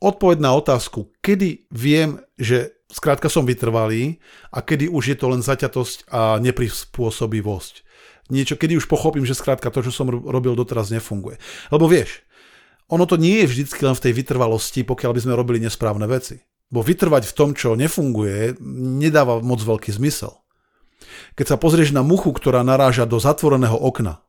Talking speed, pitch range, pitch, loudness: 165 wpm, 120-150 Hz, 130 Hz, -19 LUFS